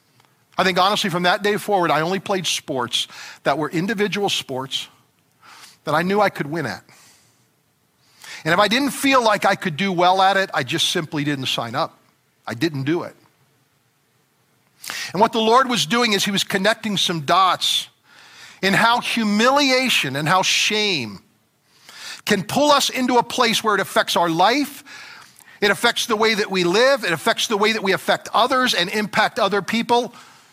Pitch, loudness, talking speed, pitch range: 200 Hz, -19 LUFS, 180 wpm, 165-225 Hz